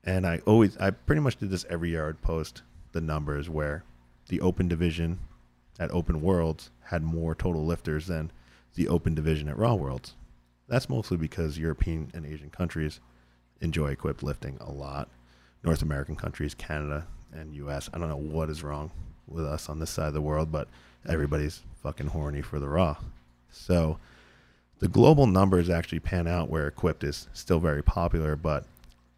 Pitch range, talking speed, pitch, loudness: 70-85 Hz, 175 wpm, 80 Hz, -29 LUFS